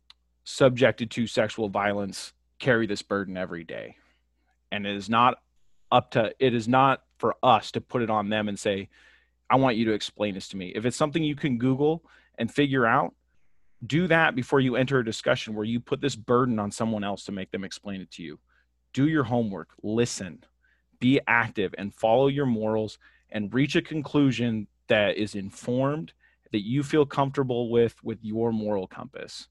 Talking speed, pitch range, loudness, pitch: 185 wpm, 100-130 Hz, -26 LUFS, 115 Hz